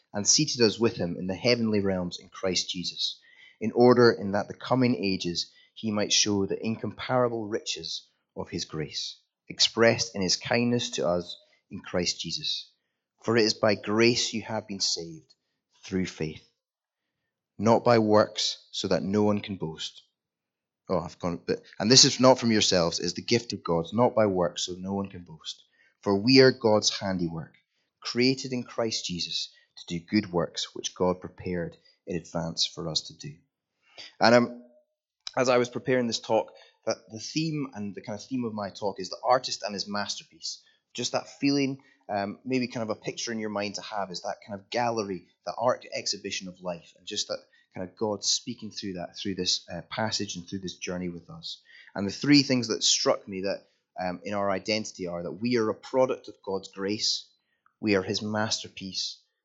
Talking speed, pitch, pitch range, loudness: 200 wpm, 105 Hz, 95-120 Hz, -27 LUFS